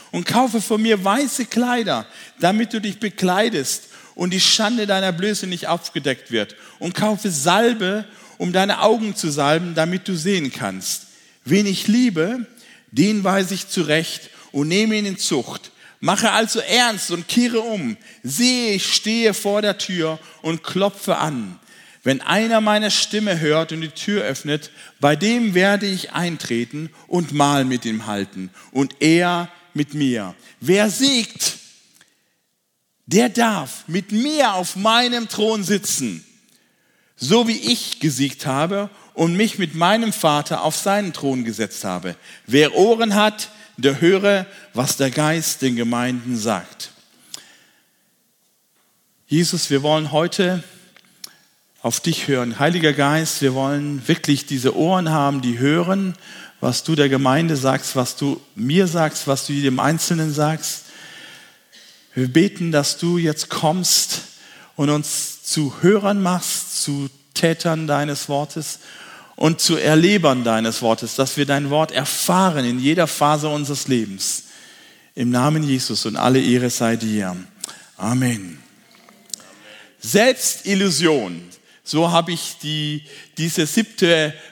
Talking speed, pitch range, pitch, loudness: 140 wpm, 140-200 Hz, 165 Hz, -19 LUFS